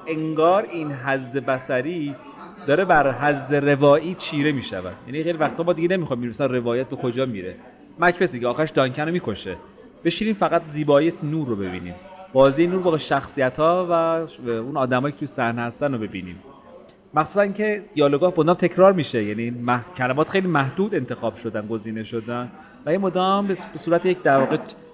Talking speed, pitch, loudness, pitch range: 165 wpm, 150 Hz, -22 LUFS, 125-175 Hz